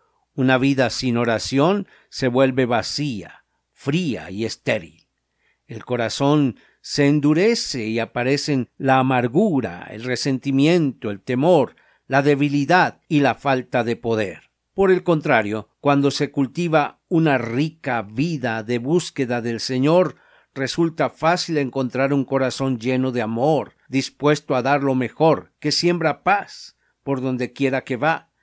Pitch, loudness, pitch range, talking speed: 135 Hz, -20 LUFS, 125-150 Hz, 135 wpm